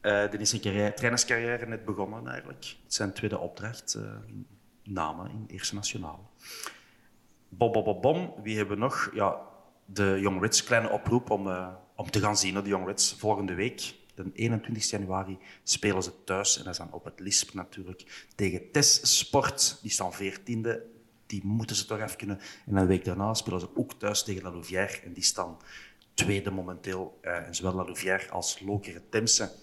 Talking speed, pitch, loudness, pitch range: 190 wpm, 100 Hz, -29 LUFS, 95-110 Hz